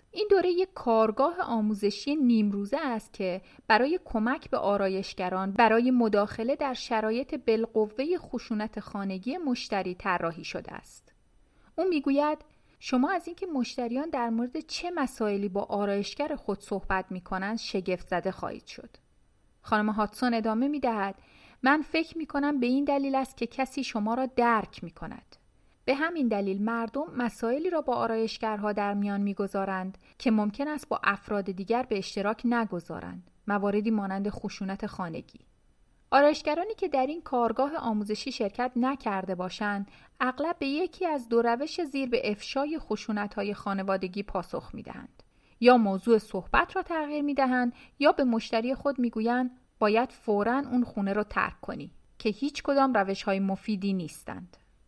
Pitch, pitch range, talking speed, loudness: 230 Hz, 200-270 Hz, 145 wpm, -29 LUFS